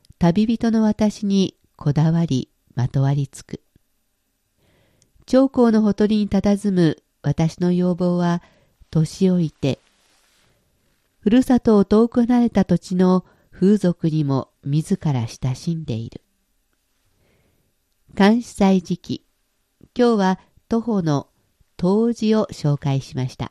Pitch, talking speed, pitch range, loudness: 180 Hz, 205 characters per minute, 150-215 Hz, -20 LUFS